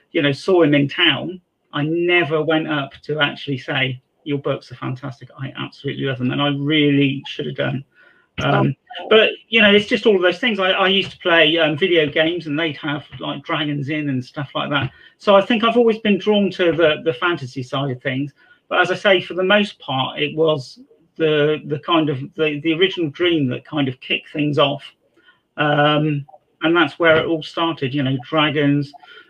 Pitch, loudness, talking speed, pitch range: 155 Hz, -18 LUFS, 210 wpm, 145-180 Hz